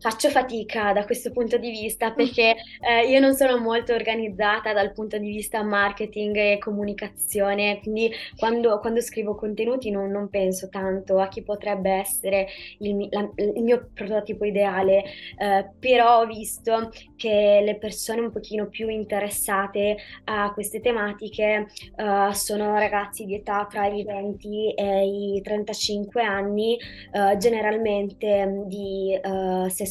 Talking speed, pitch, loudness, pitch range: 140 wpm, 210 Hz, -24 LUFS, 200-225 Hz